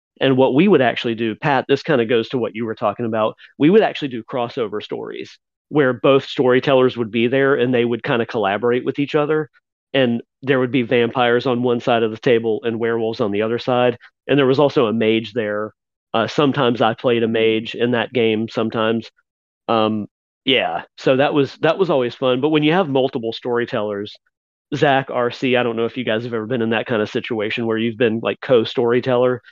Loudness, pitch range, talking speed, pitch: -18 LUFS, 115-130 Hz, 220 wpm, 120 Hz